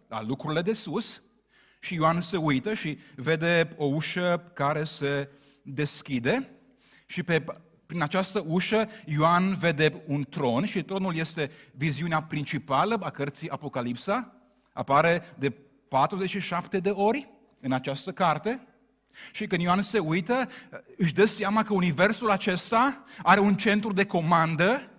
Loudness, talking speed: -27 LUFS, 135 wpm